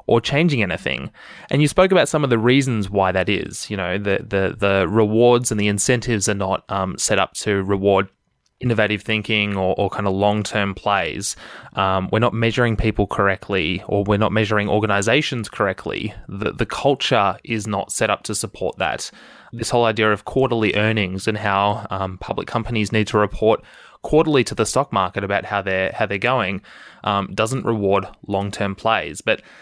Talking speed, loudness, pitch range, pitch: 190 wpm, -20 LUFS, 100-115 Hz, 105 Hz